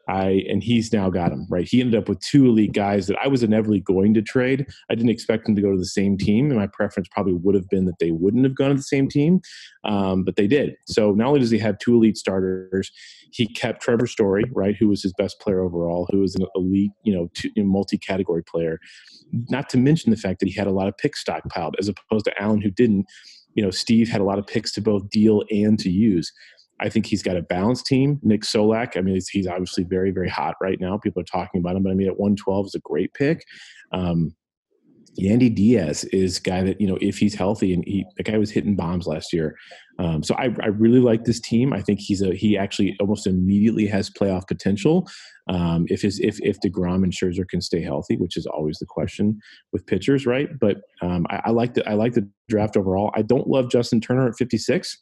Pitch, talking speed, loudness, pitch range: 100 Hz, 245 wpm, -21 LUFS, 95-115 Hz